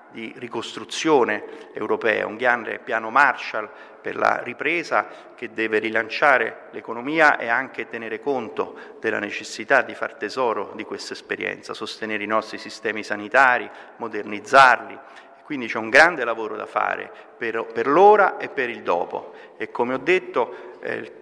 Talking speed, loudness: 145 wpm, -21 LUFS